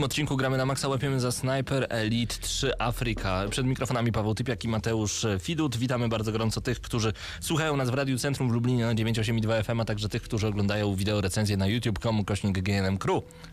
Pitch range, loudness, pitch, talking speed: 105-130 Hz, -28 LUFS, 115 Hz, 195 wpm